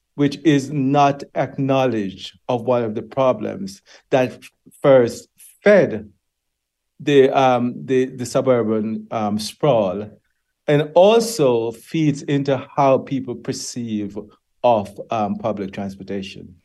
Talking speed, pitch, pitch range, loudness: 110 wpm, 125 Hz, 110-140 Hz, -19 LUFS